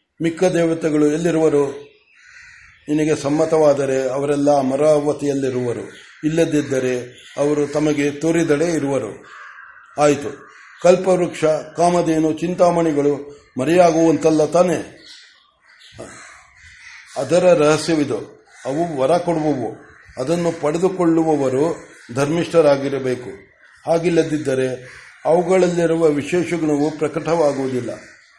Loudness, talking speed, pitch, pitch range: -18 LUFS, 60 wpm, 155 Hz, 145-170 Hz